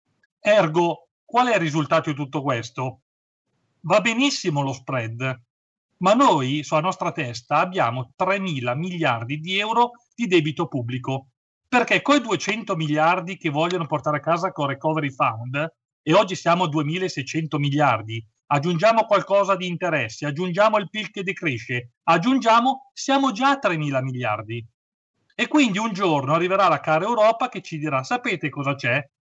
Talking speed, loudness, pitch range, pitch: 150 wpm, -22 LUFS, 140-200 Hz, 160 Hz